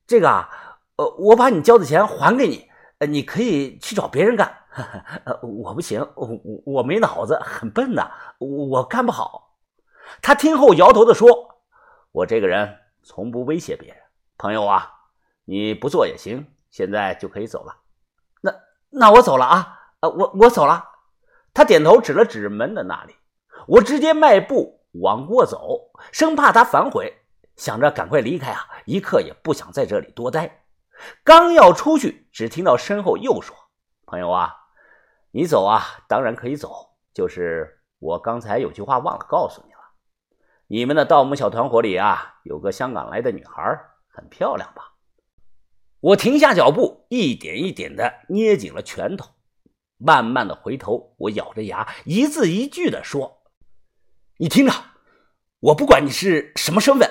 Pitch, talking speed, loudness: 305 Hz, 235 characters per minute, -17 LUFS